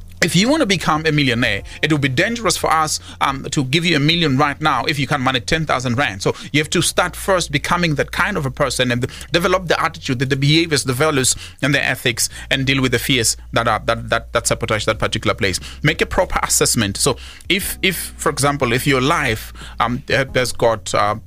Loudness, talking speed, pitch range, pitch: -17 LUFS, 230 wpm, 120-155 Hz, 140 Hz